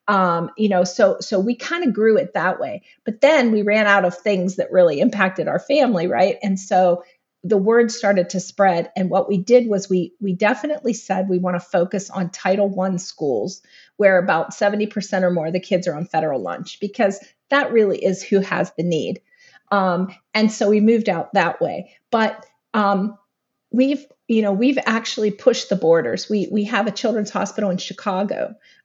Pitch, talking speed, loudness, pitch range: 200 Hz, 200 wpm, -19 LUFS, 185-225 Hz